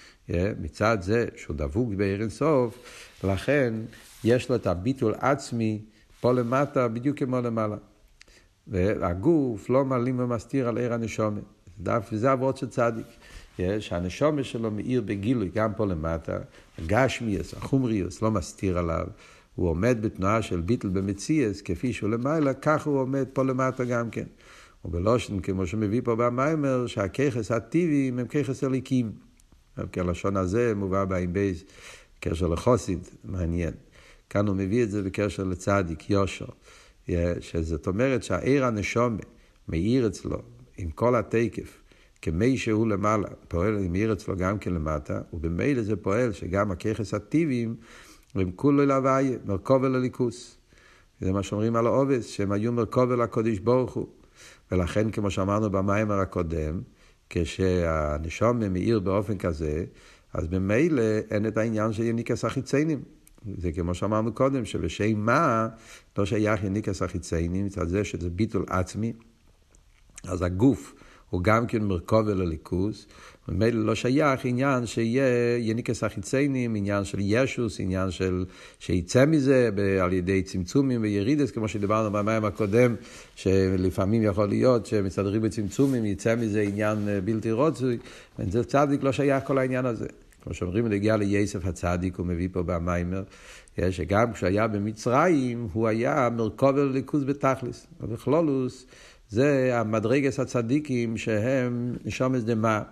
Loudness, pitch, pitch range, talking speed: -26 LUFS, 110 Hz, 95-125 Hz, 135 wpm